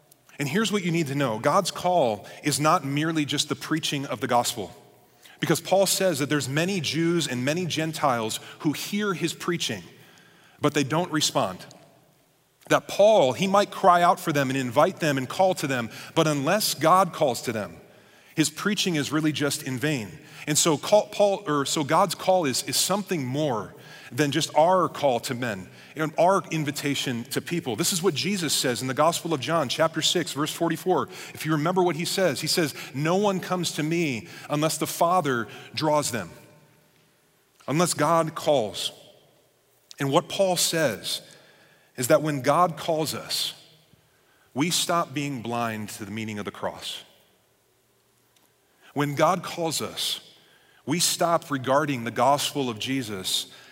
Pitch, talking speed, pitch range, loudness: 155 Hz, 170 wpm, 140-170 Hz, -24 LUFS